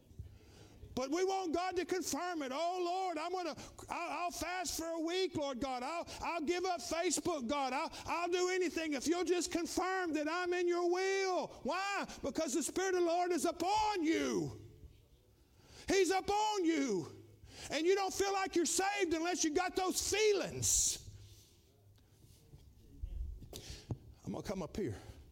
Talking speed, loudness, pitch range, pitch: 160 wpm, -36 LUFS, 280-365 Hz, 340 Hz